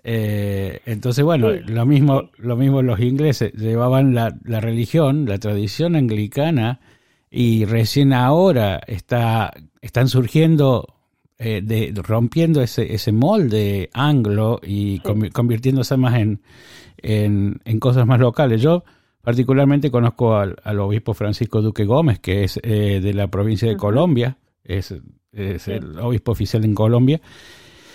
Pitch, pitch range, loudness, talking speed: 115 Hz, 105-130 Hz, -18 LUFS, 135 wpm